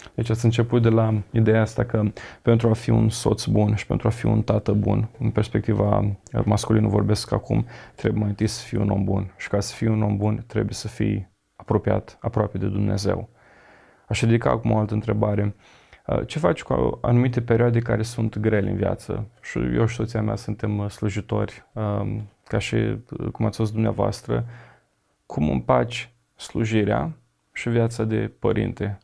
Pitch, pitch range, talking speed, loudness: 110 Hz, 105-115 Hz, 175 wpm, -23 LUFS